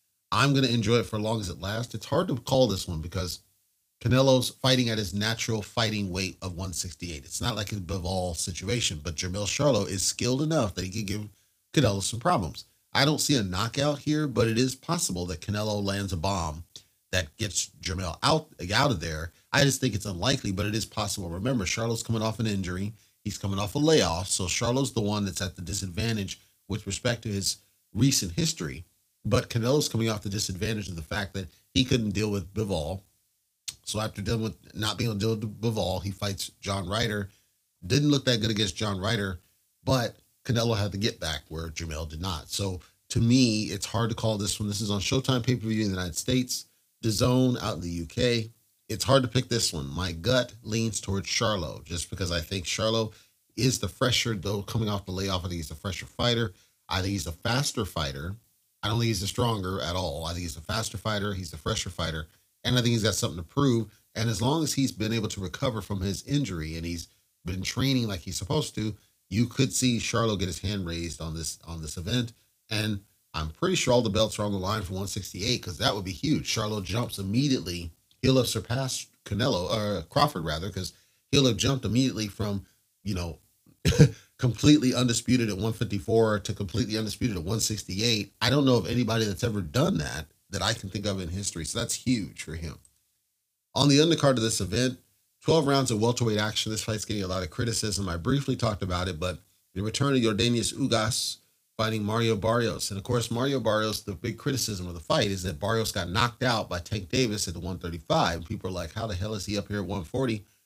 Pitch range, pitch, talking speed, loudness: 95-120 Hz, 105 Hz, 220 wpm, -28 LUFS